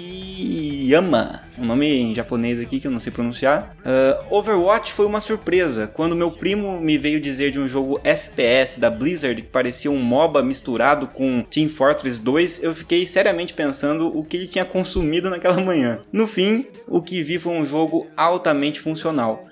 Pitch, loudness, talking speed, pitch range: 155 Hz, -20 LUFS, 180 wpm, 135-180 Hz